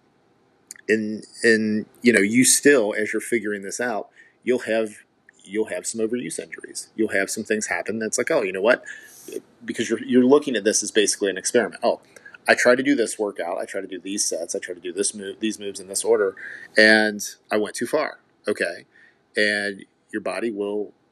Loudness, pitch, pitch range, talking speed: -22 LUFS, 110 Hz, 105-125 Hz, 205 wpm